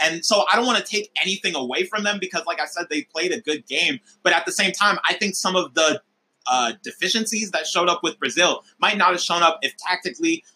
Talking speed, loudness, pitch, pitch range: 250 wpm, -21 LUFS, 185 Hz, 165-205 Hz